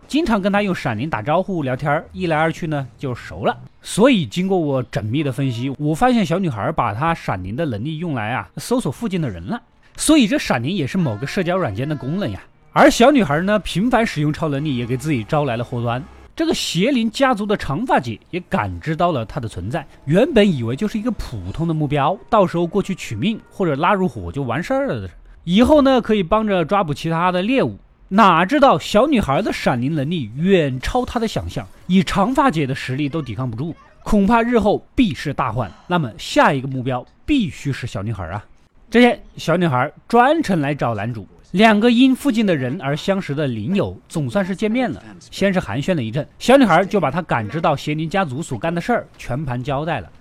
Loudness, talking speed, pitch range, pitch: -19 LUFS, 315 characters per minute, 135-205 Hz, 165 Hz